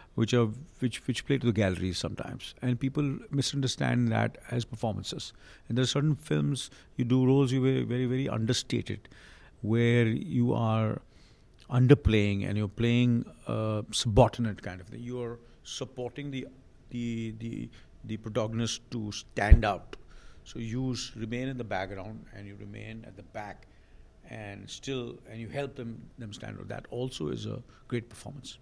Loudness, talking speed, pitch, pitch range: -30 LUFS, 165 wpm, 115 Hz, 105-125 Hz